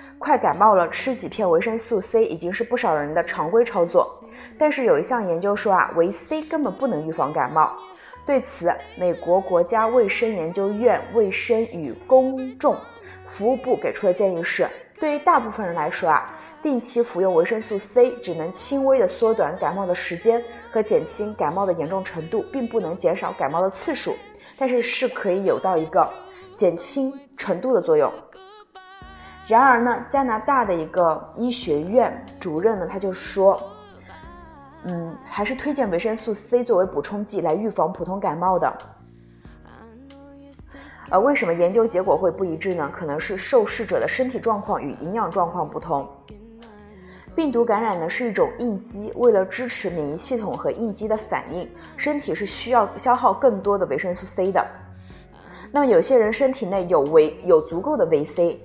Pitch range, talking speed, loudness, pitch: 180-265 Hz, 265 characters per minute, -22 LUFS, 225 Hz